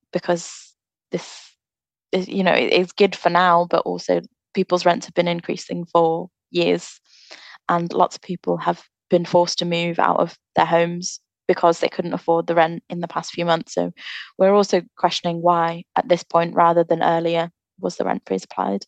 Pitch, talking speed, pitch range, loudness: 170 Hz, 185 wpm, 170-180 Hz, -20 LUFS